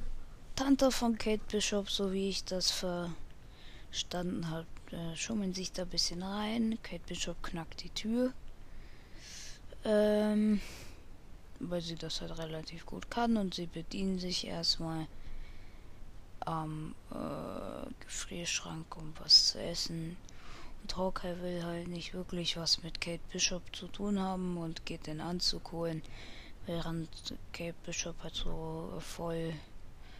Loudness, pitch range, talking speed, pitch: -35 LUFS, 155-190 Hz, 130 wpm, 170 Hz